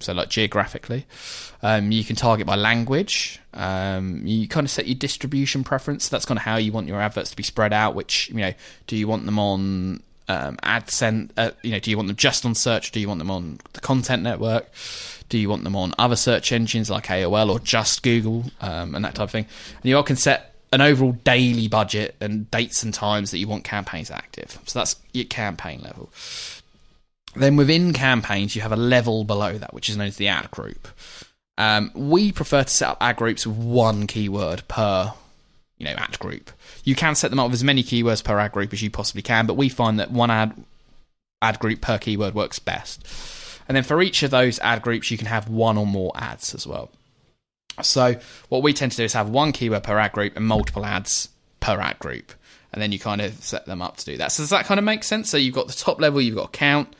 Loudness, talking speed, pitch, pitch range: -22 LUFS, 235 wpm, 110 Hz, 105-130 Hz